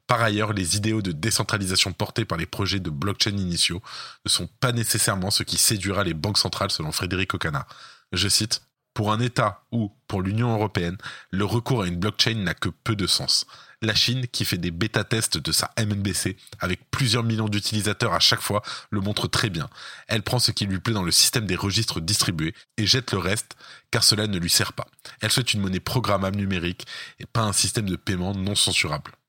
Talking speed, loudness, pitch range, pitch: 205 wpm, -23 LUFS, 95-115 Hz, 105 Hz